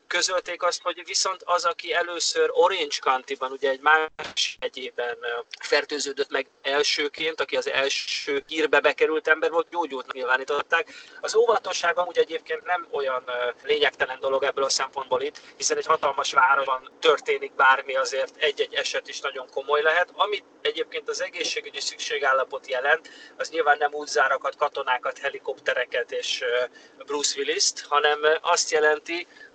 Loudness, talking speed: -24 LUFS, 140 wpm